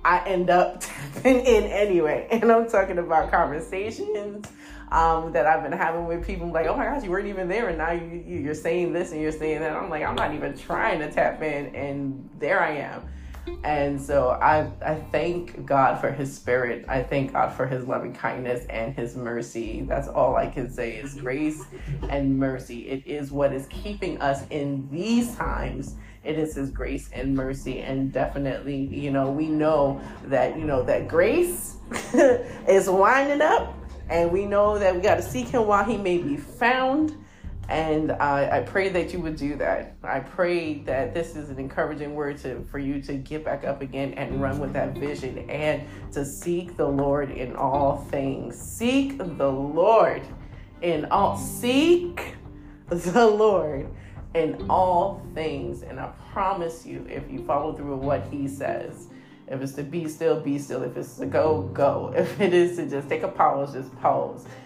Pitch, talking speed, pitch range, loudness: 155 Hz, 190 wpm, 140-180 Hz, -25 LUFS